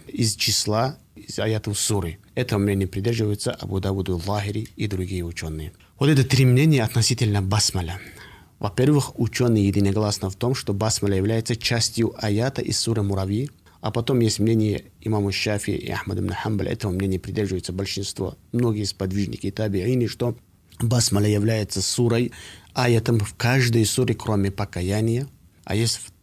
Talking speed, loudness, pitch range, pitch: 140 wpm, -23 LUFS, 95-115 Hz, 105 Hz